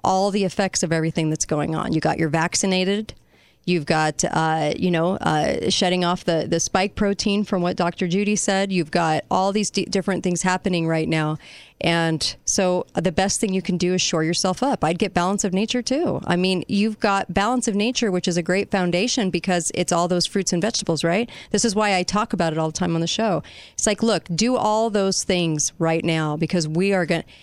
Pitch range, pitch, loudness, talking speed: 170-200 Hz, 185 Hz, -21 LUFS, 225 wpm